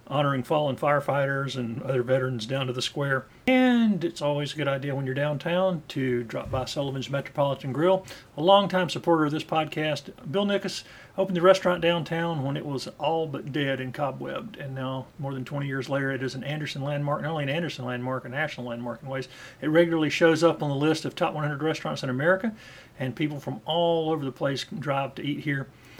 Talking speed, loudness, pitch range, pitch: 210 wpm, -27 LUFS, 135-165 Hz, 145 Hz